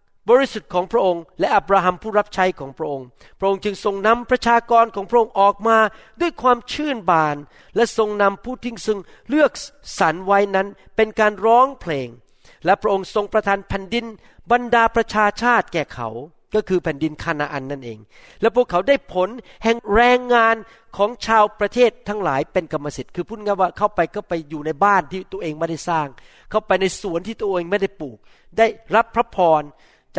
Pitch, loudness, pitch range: 205 Hz, -19 LUFS, 170-225 Hz